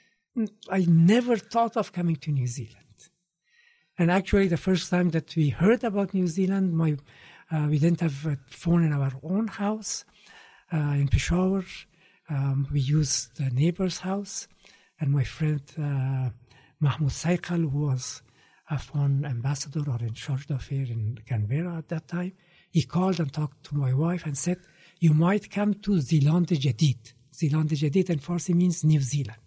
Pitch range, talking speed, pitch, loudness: 140-180 Hz, 165 wpm, 160 Hz, -26 LUFS